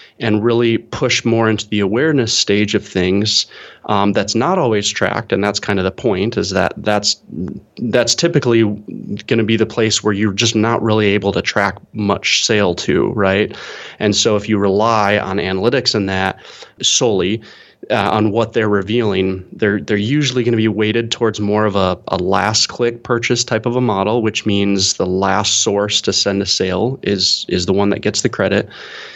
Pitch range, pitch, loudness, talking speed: 100-115 Hz, 105 Hz, -15 LUFS, 195 wpm